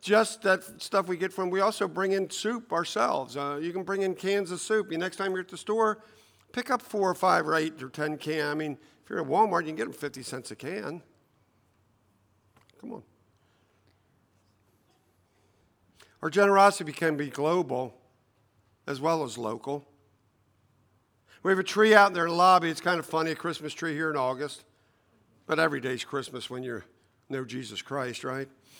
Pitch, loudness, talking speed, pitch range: 145 Hz, -28 LUFS, 190 wpm, 115-185 Hz